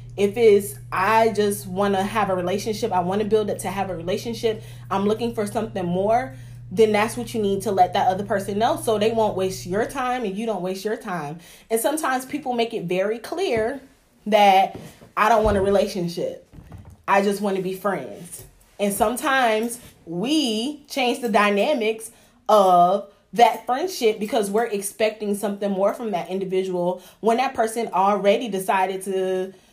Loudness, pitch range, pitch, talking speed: -22 LUFS, 190-230 Hz, 210 Hz, 180 wpm